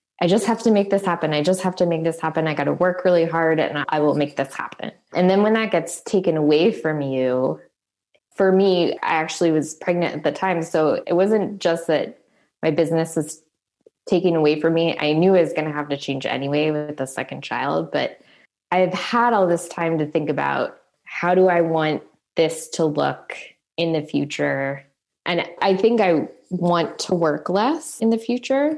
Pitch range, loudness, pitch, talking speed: 155-185 Hz, -21 LUFS, 165 Hz, 210 wpm